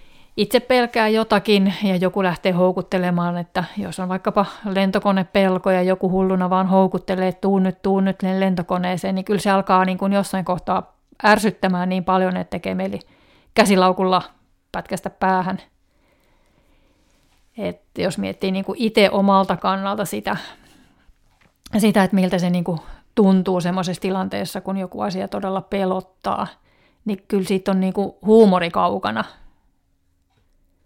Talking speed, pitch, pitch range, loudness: 140 wpm, 190 Hz, 185-195 Hz, -20 LUFS